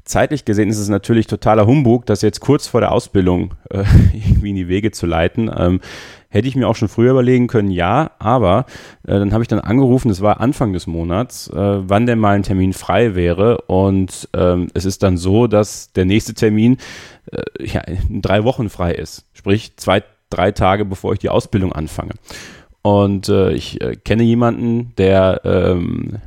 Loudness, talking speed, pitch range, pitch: -16 LUFS, 190 wpm, 95-115 Hz, 105 Hz